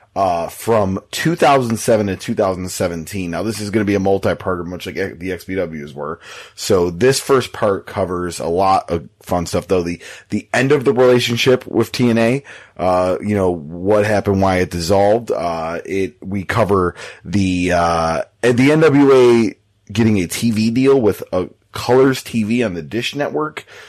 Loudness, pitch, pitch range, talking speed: -17 LUFS, 105 Hz, 90-120 Hz, 165 wpm